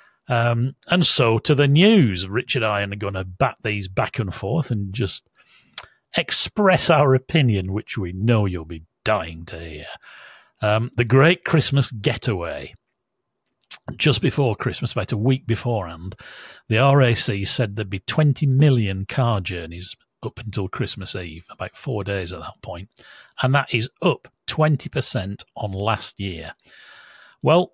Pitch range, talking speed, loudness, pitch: 100-135 Hz, 155 wpm, -20 LUFS, 115 Hz